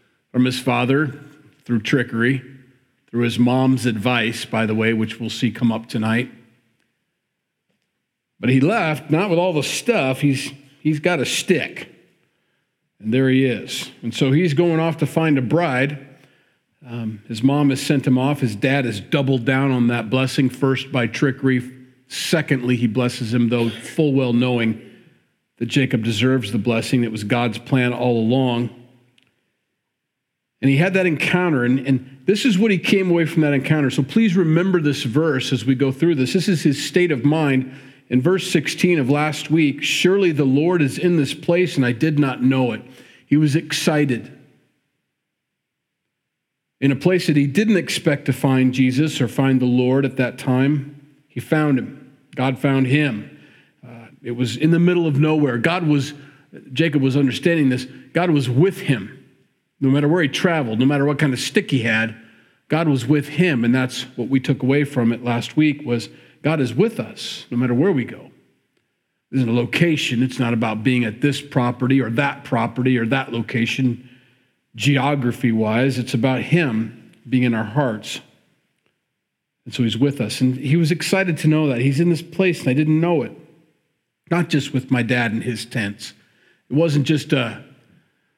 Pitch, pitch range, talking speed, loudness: 135 Hz, 125-150 Hz, 190 wpm, -19 LUFS